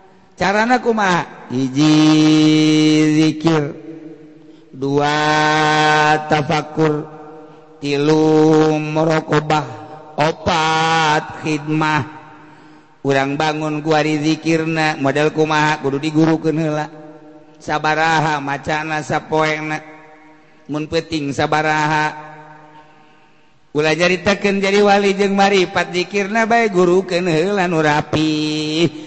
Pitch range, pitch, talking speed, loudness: 155-160 Hz, 155 Hz, 70 wpm, -16 LUFS